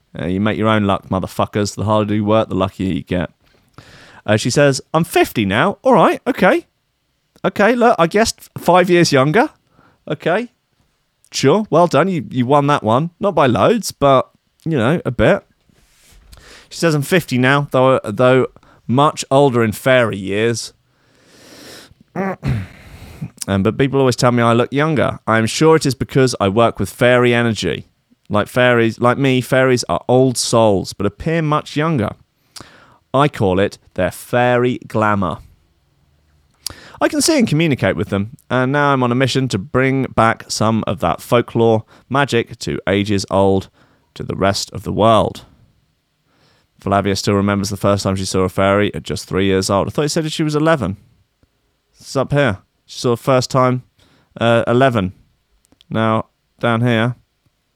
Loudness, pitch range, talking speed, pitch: -16 LUFS, 105-140 Hz, 170 wpm, 125 Hz